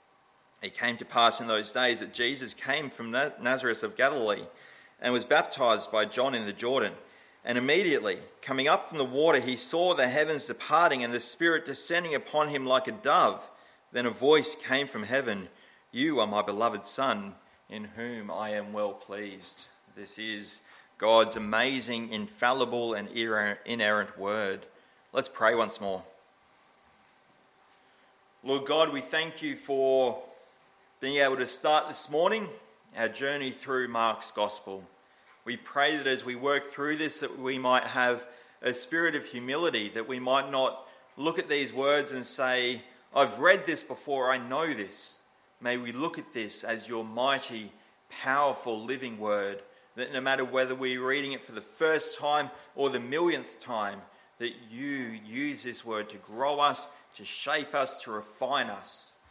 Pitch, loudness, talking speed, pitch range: 130 Hz, -29 LUFS, 165 wpm, 115-140 Hz